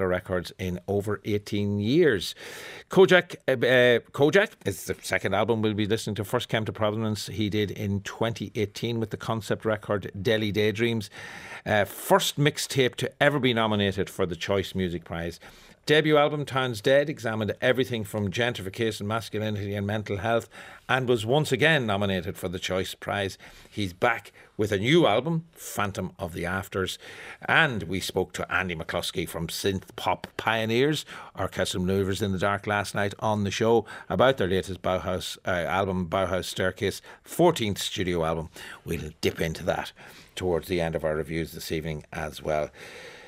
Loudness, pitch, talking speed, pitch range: -26 LUFS, 105 Hz, 165 wpm, 95-115 Hz